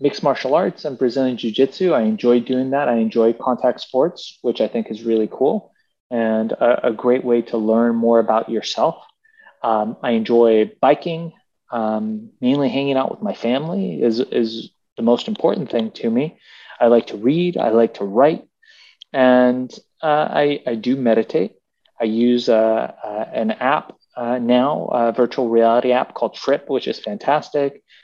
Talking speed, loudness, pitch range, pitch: 175 wpm, -19 LUFS, 115-135 Hz, 120 Hz